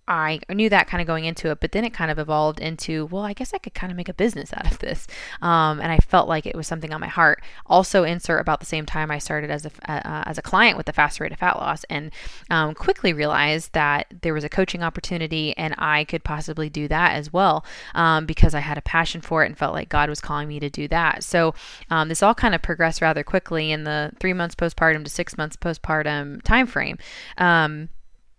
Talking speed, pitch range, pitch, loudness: 245 wpm, 155-175 Hz, 160 Hz, -22 LUFS